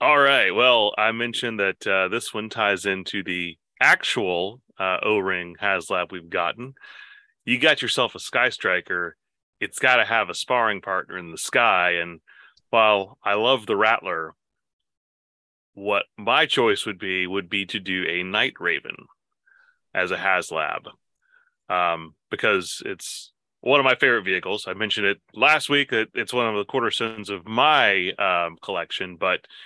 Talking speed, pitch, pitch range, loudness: 165 wpm, 100 Hz, 90-120 Hz, -22 LUFS